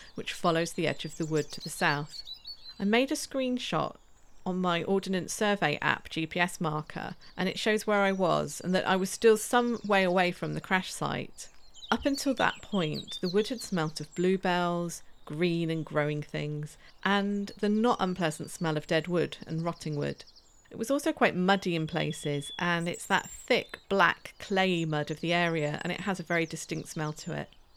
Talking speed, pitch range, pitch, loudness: 195 wpm, 155-200 Hz, 175 Hz, -30 LUFS